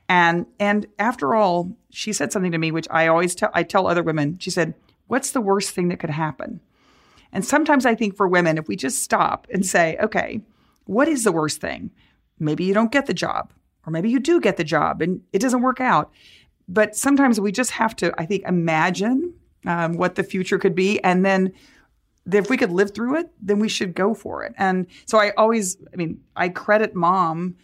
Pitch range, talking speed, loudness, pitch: 170-215 Hz, 215 wpm, -21 LUFS, 195 Hz